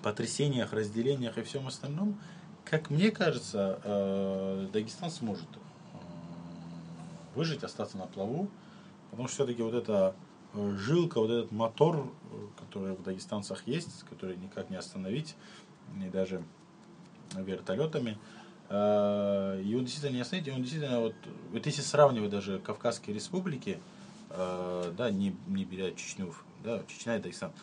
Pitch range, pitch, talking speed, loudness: 95-155 Hz, 115 Hz, 125 wpm, -33 LUFS